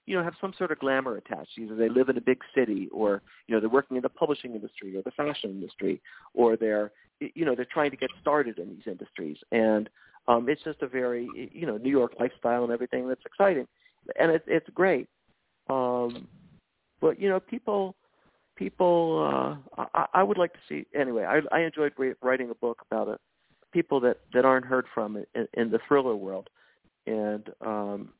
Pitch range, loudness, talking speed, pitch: 115-155 Hz, -28 LUFS, 200 wpm, 130 Hz